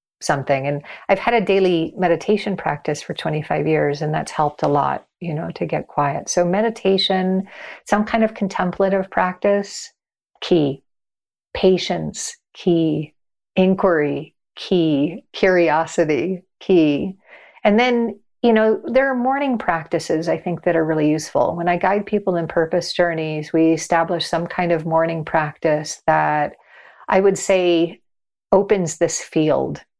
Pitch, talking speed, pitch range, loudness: 175 Hz, 140 wpm, 160-195 Hz, -19 LUFS